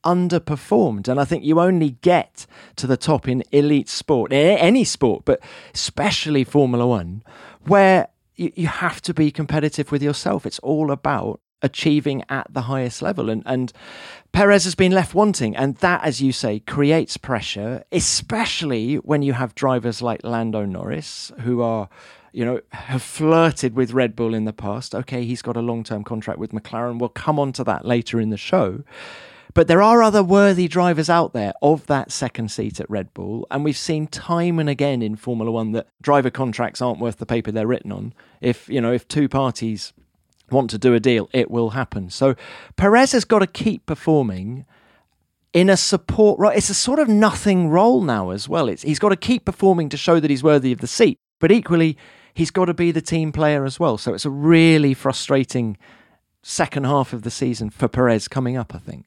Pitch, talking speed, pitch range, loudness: 135 Hz, 200 wpm, 120-165 Hz, -19 LUFS